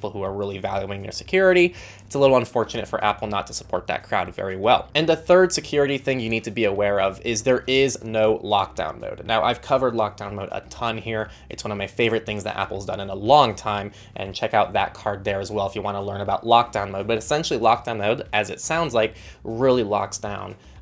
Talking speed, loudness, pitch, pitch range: 240 wpm, -22 LUFS, 110 Hz, 100-125 Hz